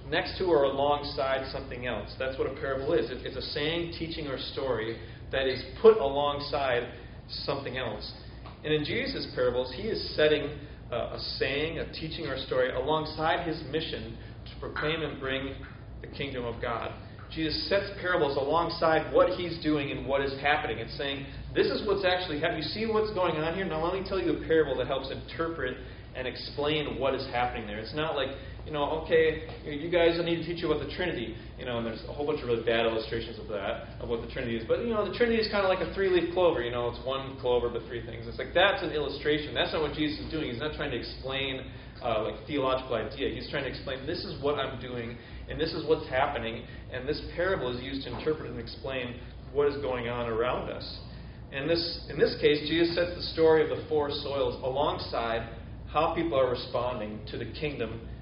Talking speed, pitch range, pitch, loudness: 220 wpm, 120-160 Hz, 140 Hz, -30 LUFS